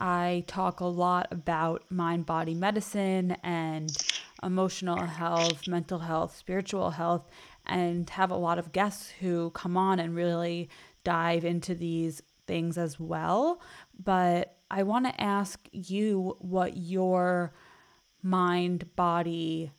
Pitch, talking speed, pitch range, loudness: 175 Hz, 125 wpm, 170-190 Hz, -30 LUFS